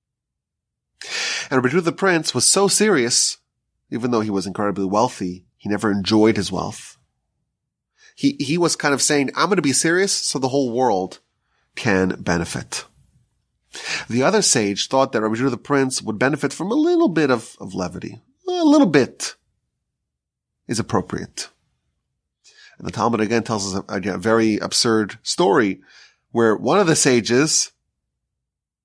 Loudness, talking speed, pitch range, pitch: -19 LUFS, 150 wpm, 110-165 Hz, 125 Hz